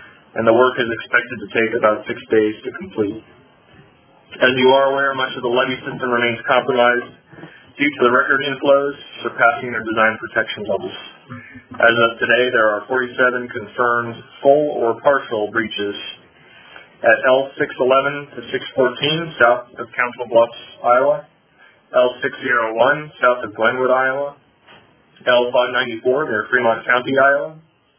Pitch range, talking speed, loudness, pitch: 115-135 Hz, 135 wpm, -17 LUFS, 125 Hz